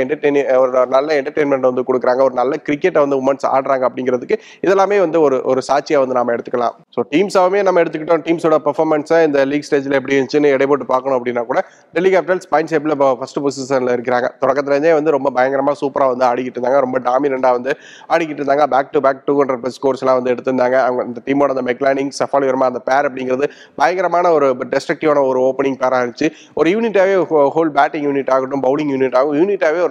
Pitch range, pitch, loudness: 130-155 Hz, 140 Hz, -16 LUFS